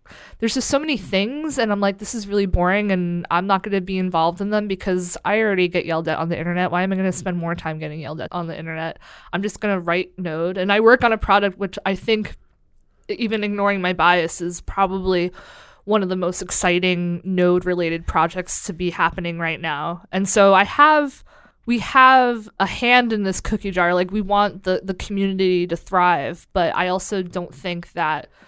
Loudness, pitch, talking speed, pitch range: -20 LUFS, 185 Hz, 215 wpm, 175-205 Hz